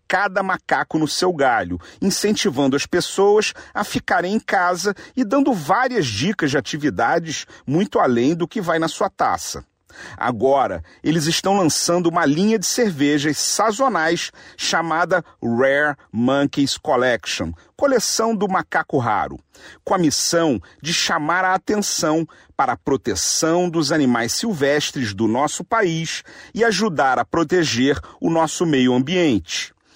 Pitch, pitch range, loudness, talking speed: 170 Hz, 145-205 Hz, -19 LUFS, 135 wpm